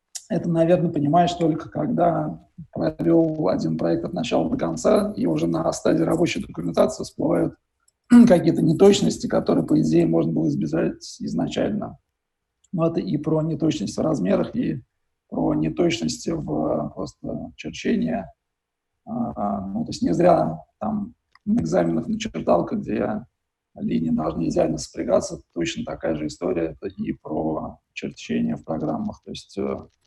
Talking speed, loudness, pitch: 135 wpm, -23 LUFS, 160 Hz